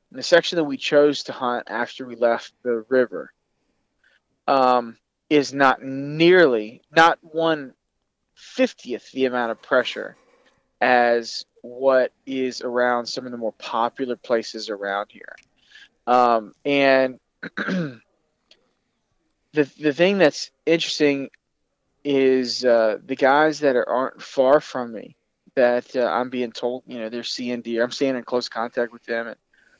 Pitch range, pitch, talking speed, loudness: 120-140 Hz, 125 Hz, 140 wpm, -21 LUFS